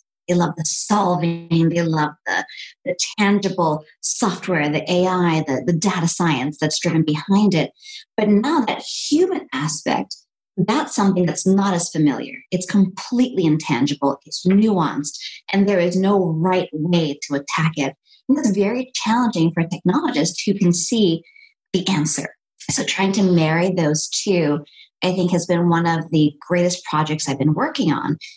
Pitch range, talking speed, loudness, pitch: 155-200 Hz, 160 wpm, -19 LUFS, 175 Hz